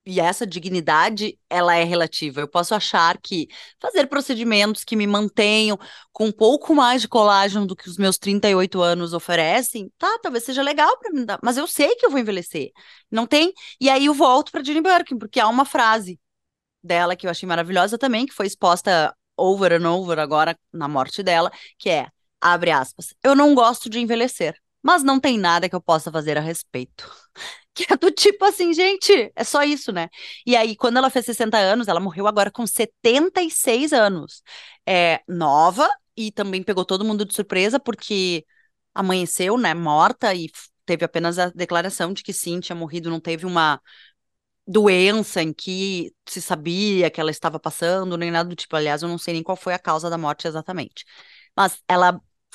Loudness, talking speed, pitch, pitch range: -20 LUFS, 185 wpm, 195 Hz, 170-240 Hz